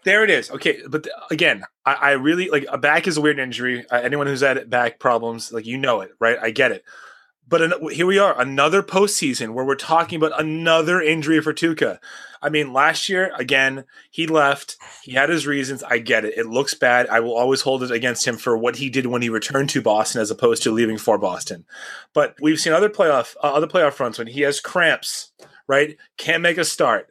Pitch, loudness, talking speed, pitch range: 140 Hz, -19 LUFS, 225 wpm, 125-160 Hz